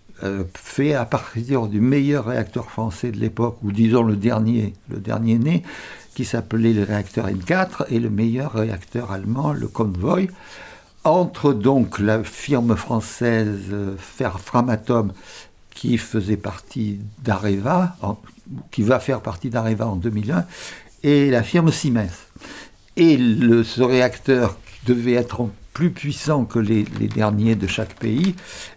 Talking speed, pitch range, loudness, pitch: 135 wpm, 105-130 Hz, -21 LUFS, 115 Hz